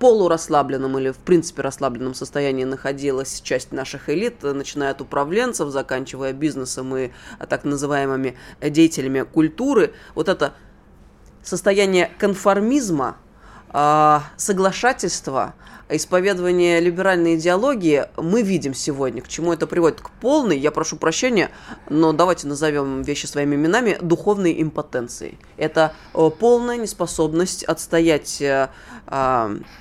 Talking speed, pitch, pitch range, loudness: 105 wpm, 155 Hz, 140-180 Hz, -20 LUFS